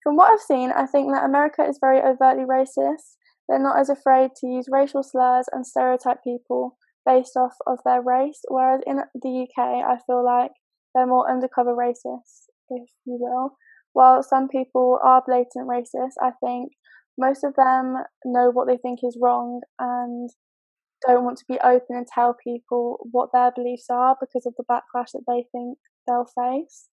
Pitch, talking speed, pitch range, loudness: 250 Hz, 180 wpm, 245-265 Hz, -21 LUFS